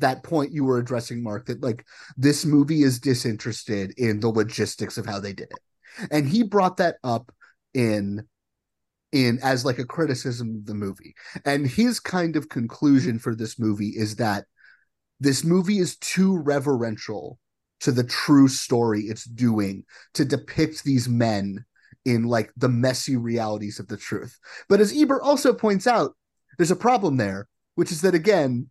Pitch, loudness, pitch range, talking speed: 130 Hz, -23 LUFS, 115-155 Hz, 170 wpm